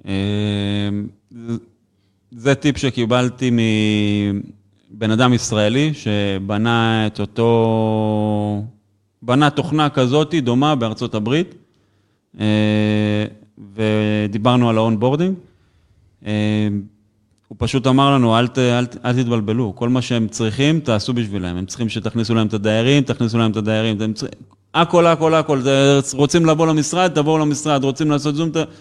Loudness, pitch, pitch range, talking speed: -17 LUFS, 115 Hz, 105-135 Hz, 125 wpm